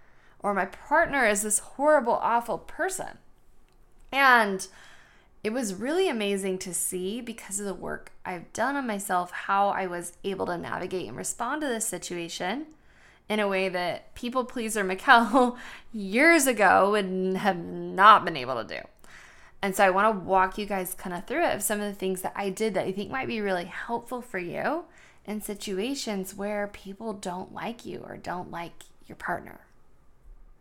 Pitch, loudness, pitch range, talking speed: 205 Hz, -26 LUFS, 190-240 Hz, 180 wpm